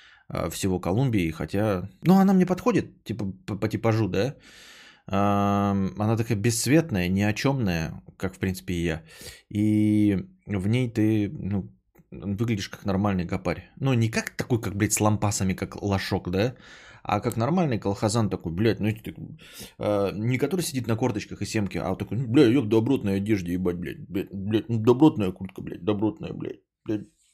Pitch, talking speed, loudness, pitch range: 105 Hz, 170 wpm, -25 LUFS, 95-115 Hz